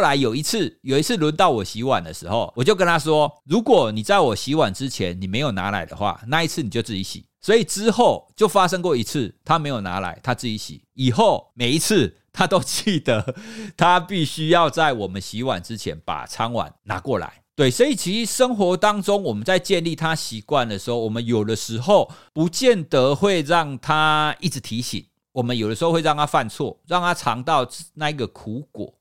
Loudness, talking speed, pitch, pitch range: -21 LUFS, 300 characters per minute, 150 Hz, 115-175 Hz